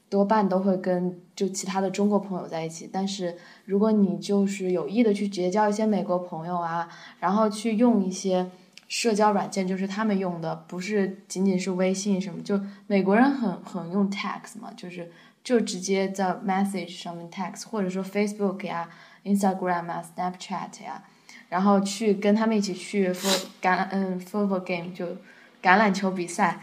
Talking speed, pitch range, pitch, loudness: 335 characters per minute, 180-205 Hz, 190 Hz, -26 LUFS